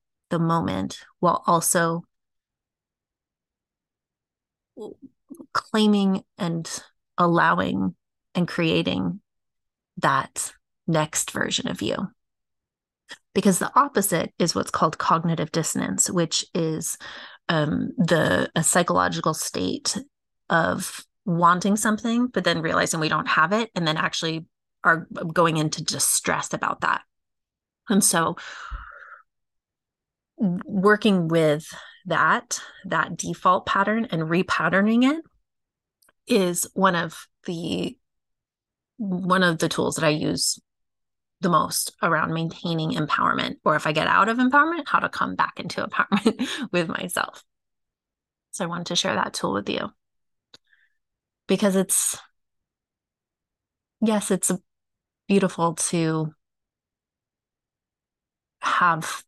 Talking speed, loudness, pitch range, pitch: 105 wpm, -23 LUFS, 160-205 Hz, 175 Hz